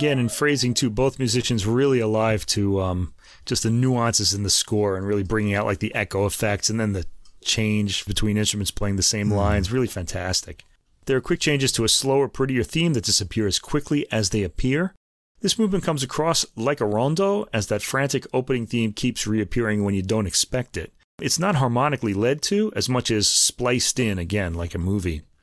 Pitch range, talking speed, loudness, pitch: 100-130 Hz, 200 wpm, -22 LUFS, 110 Hz